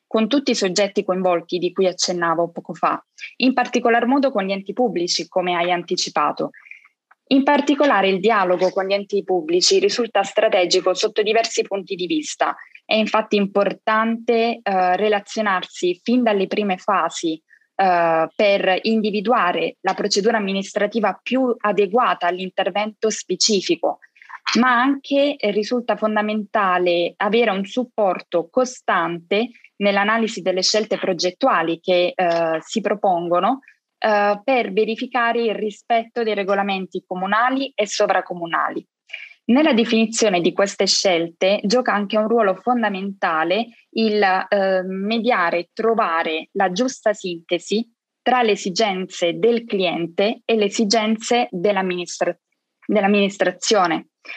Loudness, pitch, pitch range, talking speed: -19 LUFS, 205 Hz, 185-235 Hz, 120 wpm